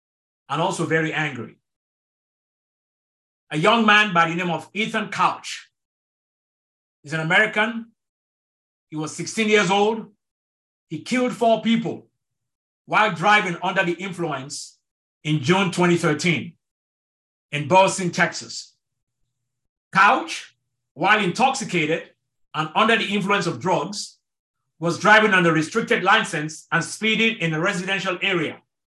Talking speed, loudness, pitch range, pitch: 115 wpm, -20 LUFS, 155-210 Hz, 175 Hz